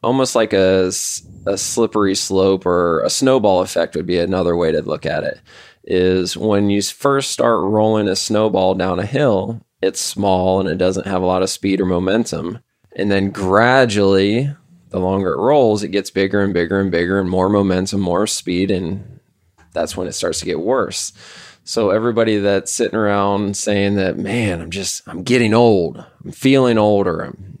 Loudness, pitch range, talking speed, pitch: -17 LUFS, 95-110 Hz, 185 wpm, 100 Hz